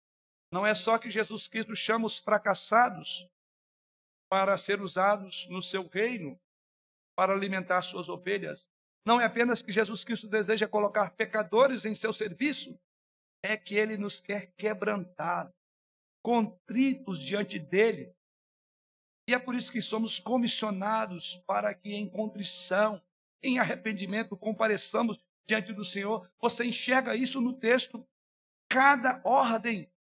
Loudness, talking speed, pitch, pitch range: -29 LUFS, 130 wpm, 215 Hz, 190-225 Hz